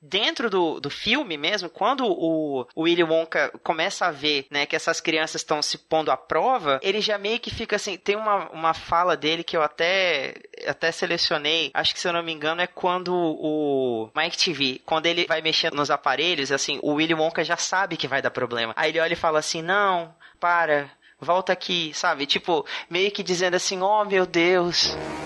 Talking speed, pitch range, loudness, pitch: 200 wpm, 155-185 Hz, -23 LUFS, 165 Hz